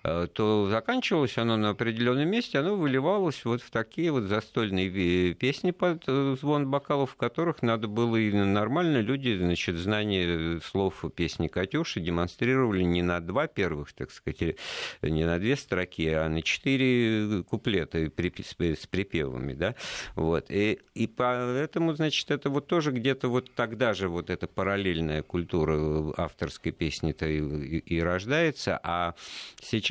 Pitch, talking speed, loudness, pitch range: 110 Hz, 140 wpm, -28 LUFS, 85-135 Hz